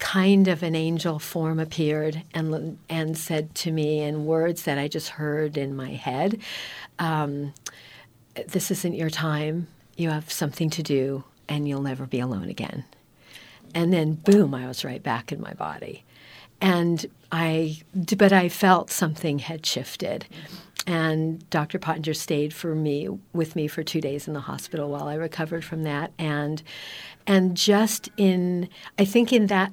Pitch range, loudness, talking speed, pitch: 150-175 Hz, -25 LUFS, 165 wpm, 160 Hz